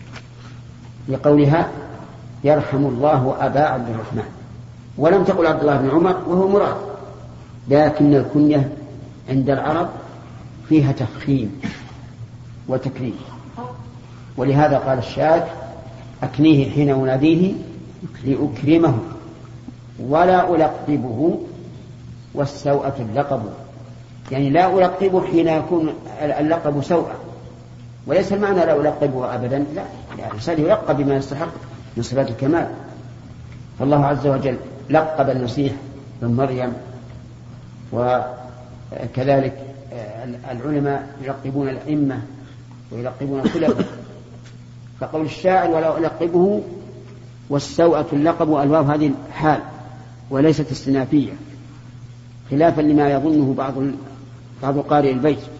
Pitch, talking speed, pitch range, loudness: 135 Hz, 90 wpm, 125-150 Hz, -19 LUFS